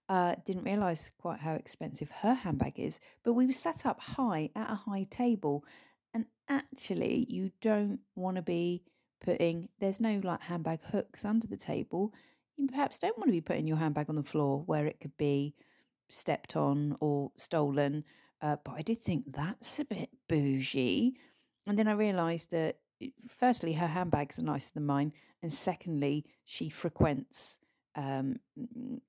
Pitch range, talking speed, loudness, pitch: 150-230 Hz, 165 wpm, -34 LUFS, 175 Hz